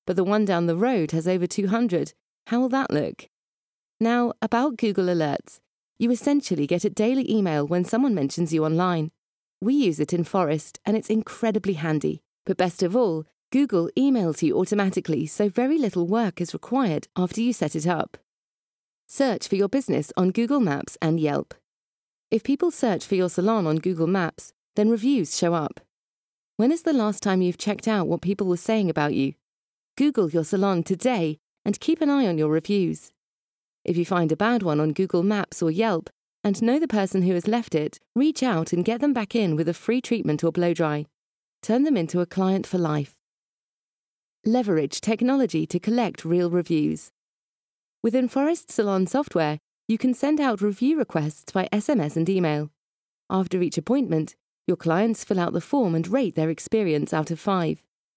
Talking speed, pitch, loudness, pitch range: 185 wpm, 190 Hz, -24 LUFS, 165-235 Hz